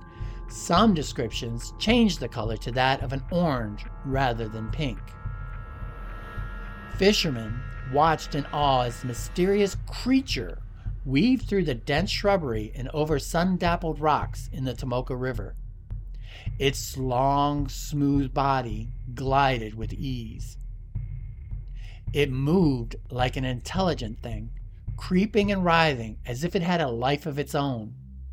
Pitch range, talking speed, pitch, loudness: 110-150 Hz, 125 wpm, 130 Hz, -26 LUFS